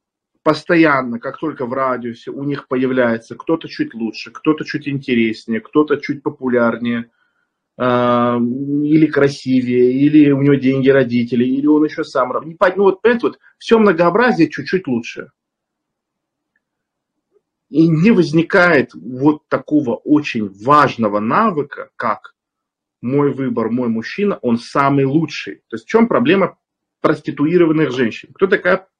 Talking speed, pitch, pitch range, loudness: 130 wpm, 140 Hz, 125-160 Hz, -16 LUFS